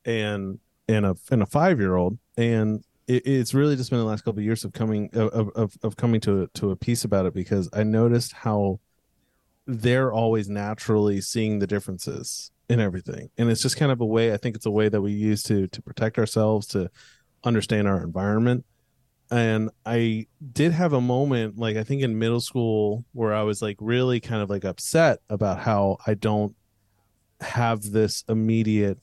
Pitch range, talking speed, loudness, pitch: 105-120 Hz, 195 wpm, -24 LUFS, 110 Hz